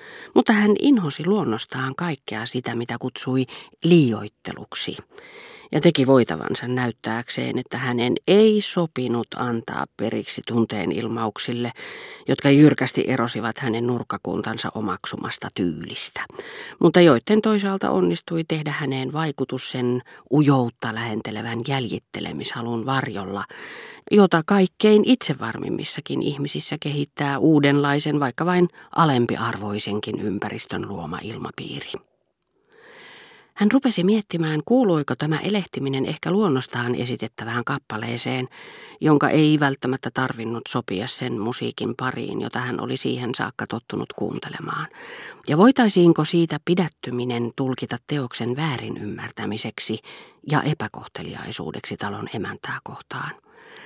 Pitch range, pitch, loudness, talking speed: 120-170 Hz, 135 Hz, -22 LUFS, 100 wpm